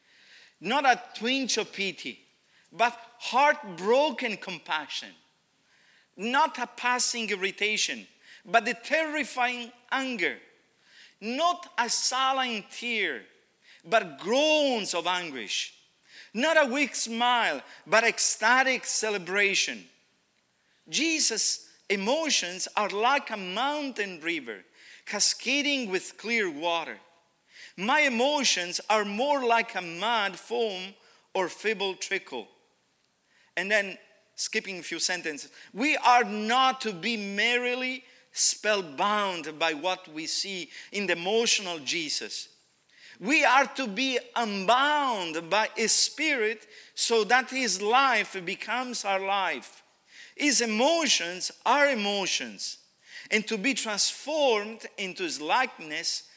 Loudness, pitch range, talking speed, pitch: -26 LUFS, 200-260 Hz, 105 wpm, 230 Hz